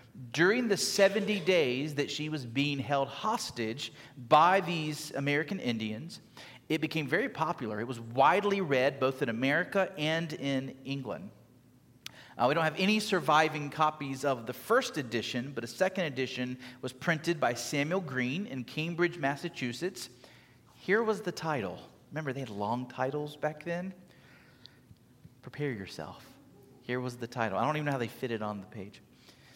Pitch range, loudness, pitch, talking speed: 125-160 Hz, -31 LUFS, 140 Hz, 160 wpm